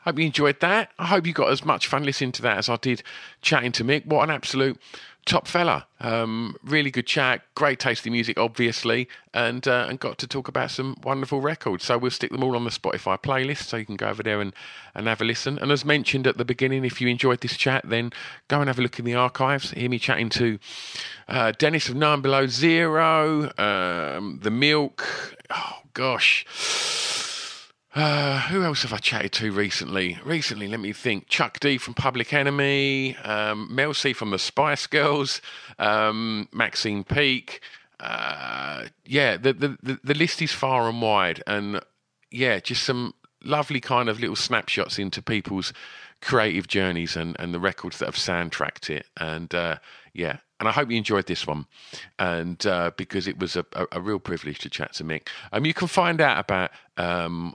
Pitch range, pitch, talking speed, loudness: 105-140 Hz, 125 Hz, 195 wpm, -24 LUFS